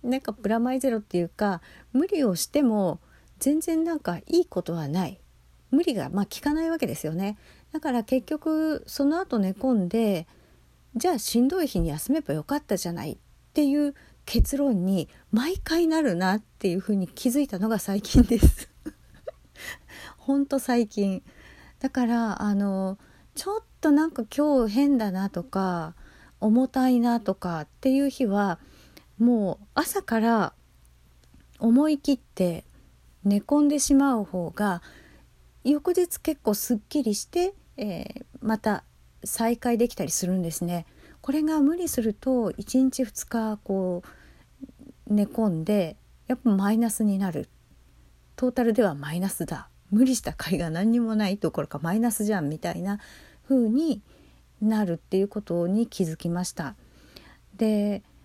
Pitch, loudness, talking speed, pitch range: 220 Hz, -26 LUFS, 285 characters per minute, 190-270 Hz